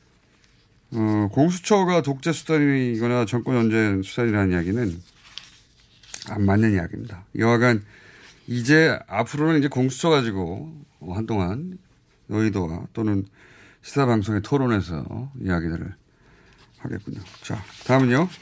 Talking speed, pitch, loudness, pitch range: 270 characters per minute, 115 Hz, -22 LUFS, 100-140 Hz